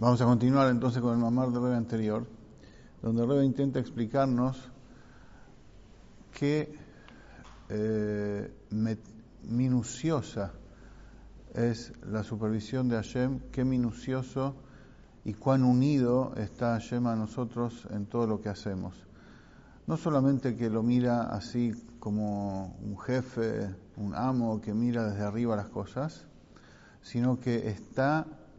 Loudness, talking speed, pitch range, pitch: -31 LUFS, 120 wpm, 110-130 Hz, 120 Hz